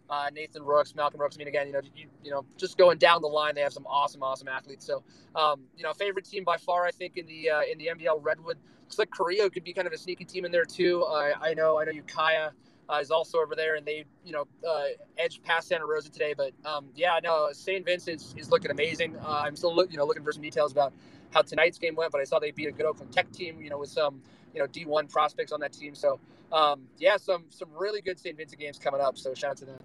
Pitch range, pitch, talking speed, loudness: 145-175 Hz, 155 Hz, 275 wpm, -29 LUFS